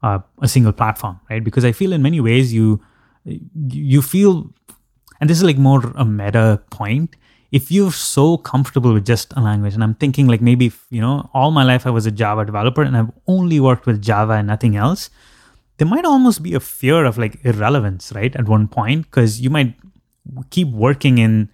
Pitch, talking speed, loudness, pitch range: 125 Hz, 205 wpm, -16 LUFS, 110-145 Hz